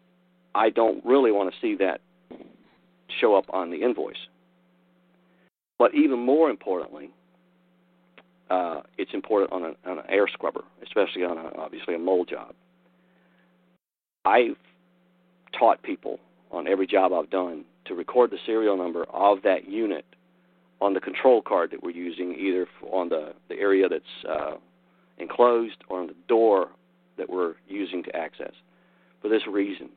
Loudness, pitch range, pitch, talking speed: -25 LUFS, 115-180 Hz, 180 Hz, 150 wpm